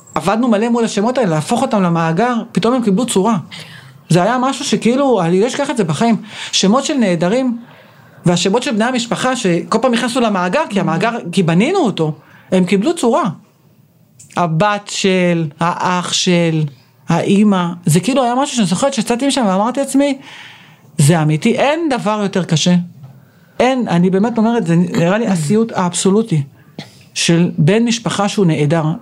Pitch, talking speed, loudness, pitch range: 195 Hz, 155 wpm, -15 LUFS, 170-230 Hz